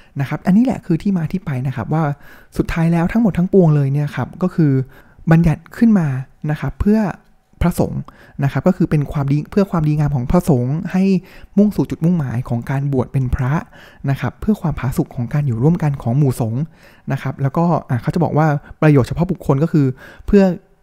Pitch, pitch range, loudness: 155 Hz, 135-180 Hz, -17 LUFS